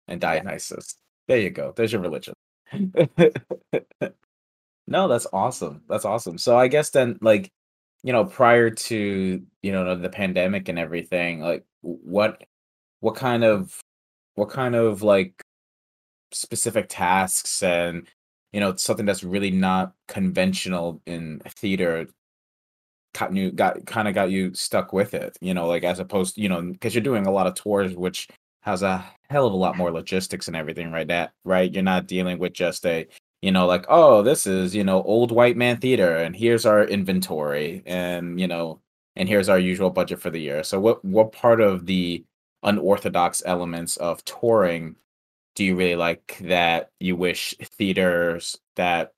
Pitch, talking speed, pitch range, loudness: 95 Hz, 170 wpm, 85-105 Hz, -22 LUFS